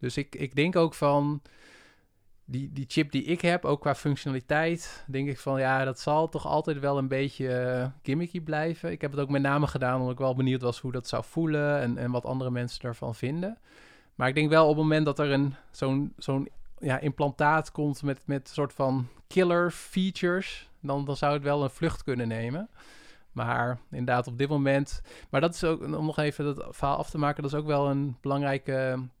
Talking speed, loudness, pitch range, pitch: 215 wpm, -28 LUFS, 130-150 Hz, 140 Hz